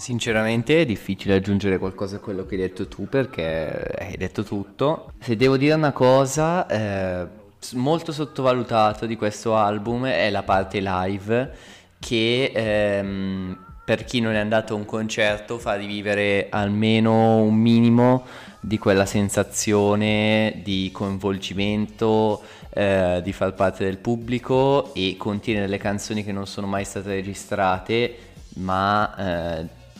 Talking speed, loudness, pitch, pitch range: 135 wpm, -22 LUFS, 105 Hz, 95-115 Hz